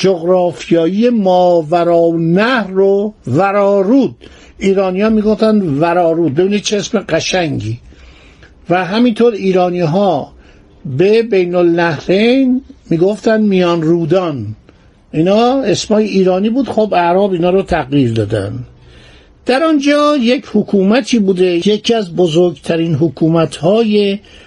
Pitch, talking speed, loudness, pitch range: 185 Hz, 110 wpm, -12 LUFS, 165-210 Hz